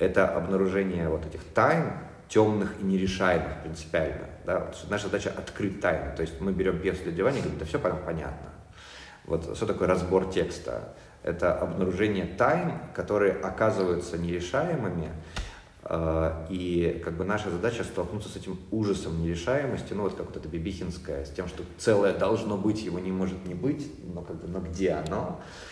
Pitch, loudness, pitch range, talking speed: 95 Hz, -29 LUFS, 85-95 Hz, 165 wpm